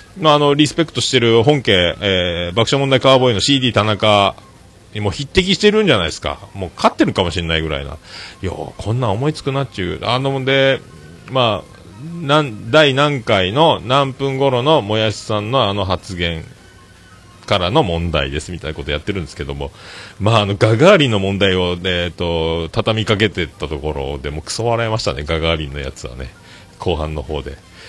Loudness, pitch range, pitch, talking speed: -16 LUFS, 85-130 Hz, 100 Hz, 375 characters per minute